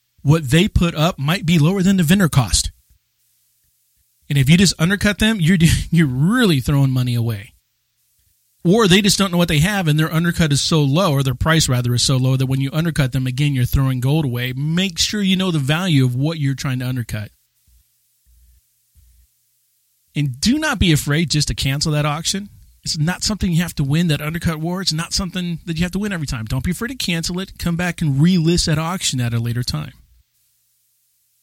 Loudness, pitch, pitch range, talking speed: -17 LUFS, 155 Hz, 130-175 Hz, 215 wpm